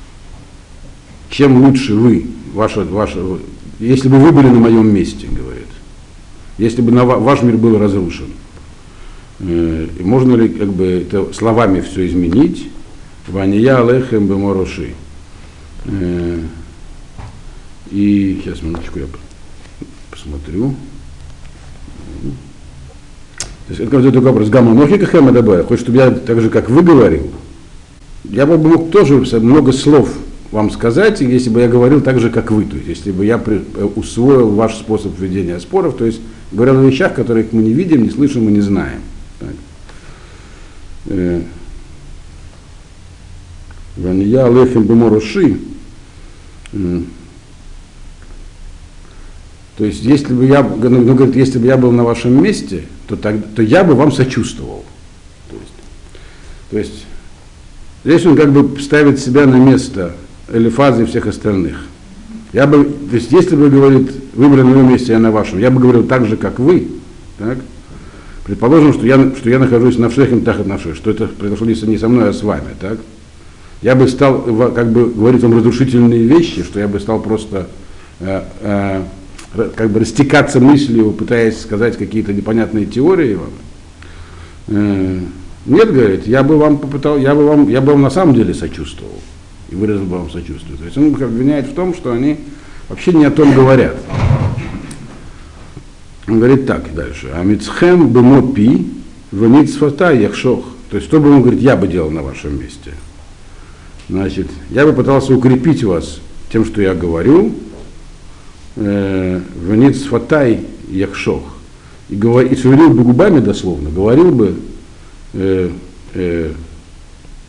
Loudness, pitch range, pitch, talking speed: -11 LUFS, 85-125 Hz, 105 Hz, 140 wpm